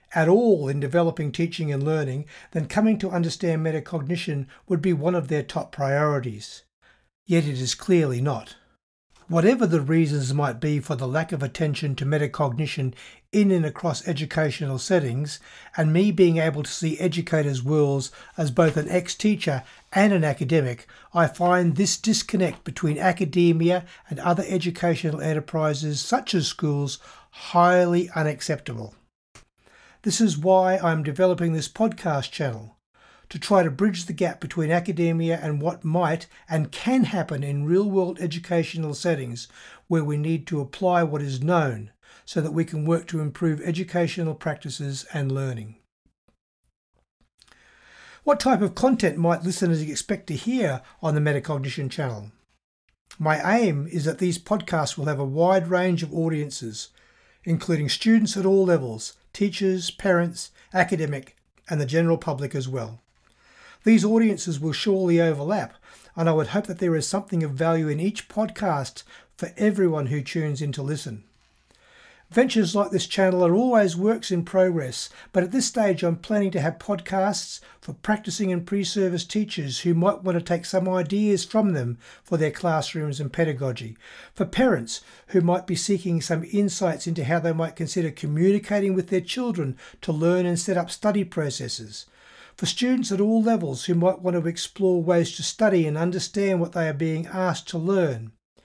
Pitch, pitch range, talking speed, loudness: 170 Hz, 150-185 Hz, 160 wpm, -24 LUFS